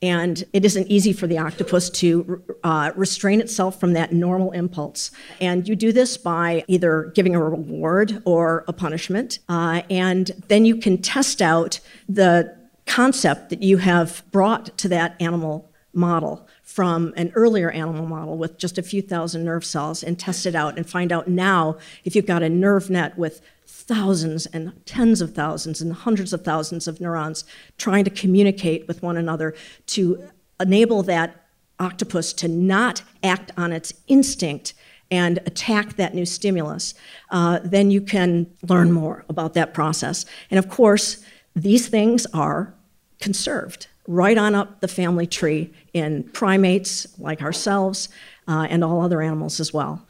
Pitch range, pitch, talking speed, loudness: 165-195 Hz, 180 Hz, 165 wpm, -21 LUFS